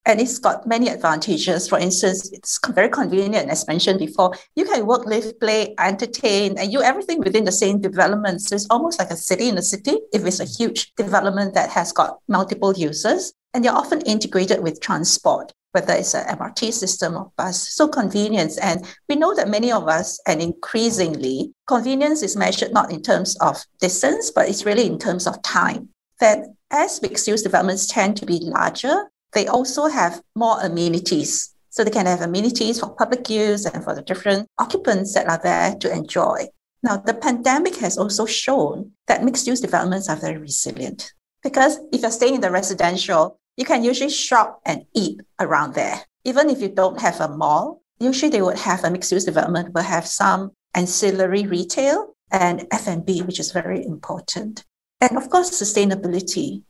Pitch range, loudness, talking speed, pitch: 185-250 Hz, -20 LUFS, 185 wpm, 210 Hz